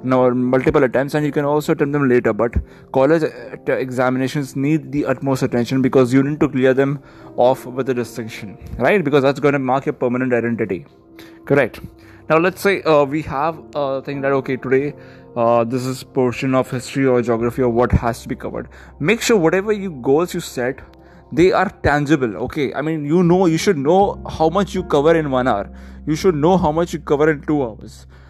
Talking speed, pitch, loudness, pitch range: 210 wpm, 135 Hz, -18 LUFS, 125-155 Hz